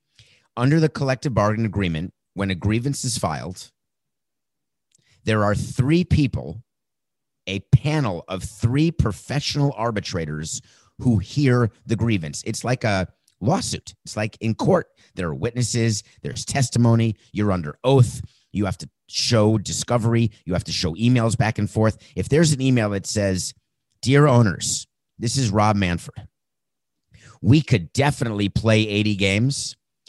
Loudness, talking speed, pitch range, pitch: -22 LUFS, 140 wpm, 100-125 Hz, 115 Hz